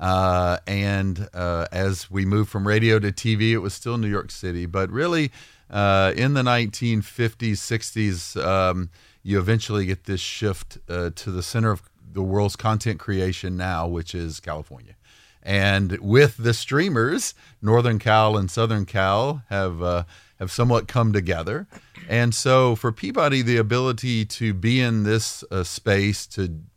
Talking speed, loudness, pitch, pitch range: 155 wpm, -22 LUFS, 105 Hz, 95-115 Hz